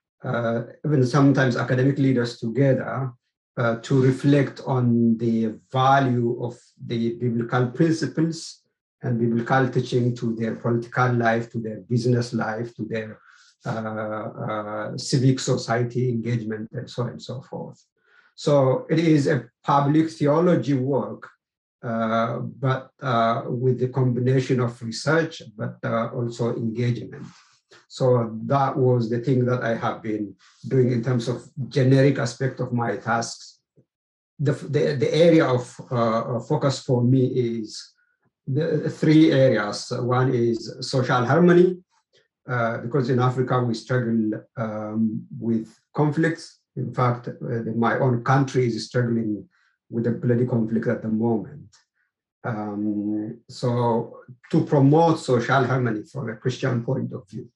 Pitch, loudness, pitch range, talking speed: 125 Hz, -23 LUFS, 115-135 Hz, 135 wpm